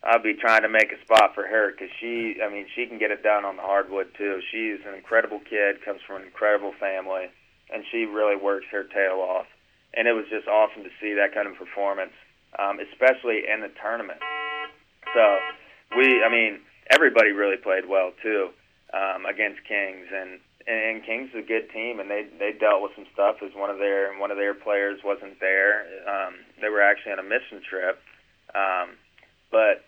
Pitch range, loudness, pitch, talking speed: 100-110 Hz, -24 LUFS, 100 Hz, 205 wpm